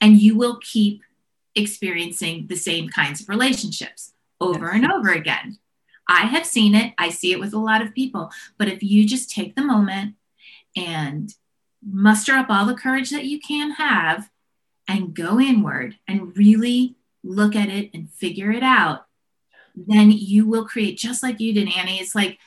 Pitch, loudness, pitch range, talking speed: 210 Hz, -19 LUFS, 195-240 Hz, 175 wpm